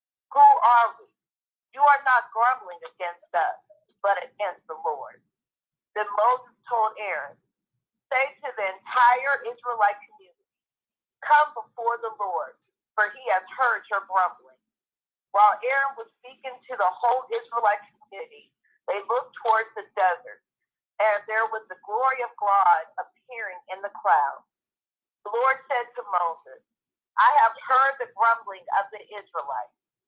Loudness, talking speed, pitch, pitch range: -24 LUFS, 140 wpm, 235 Hz, 205-265 Hz